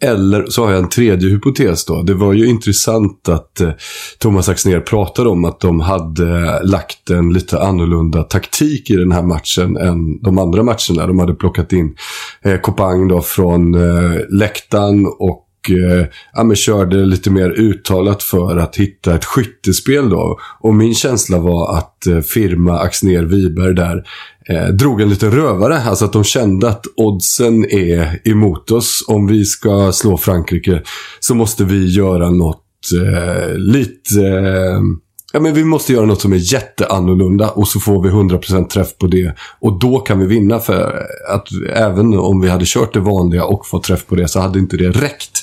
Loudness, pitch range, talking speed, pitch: -13 LUFS, 90-110 Hz, 180 wpm, 95 Hz